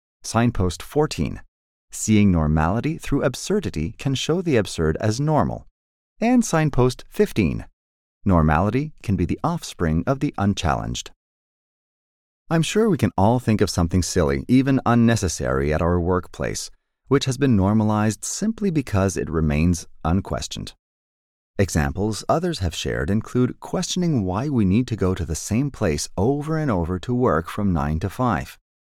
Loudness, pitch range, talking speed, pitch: -22 LUFS, 85-135 Hz, 145 wpm, 105 Hz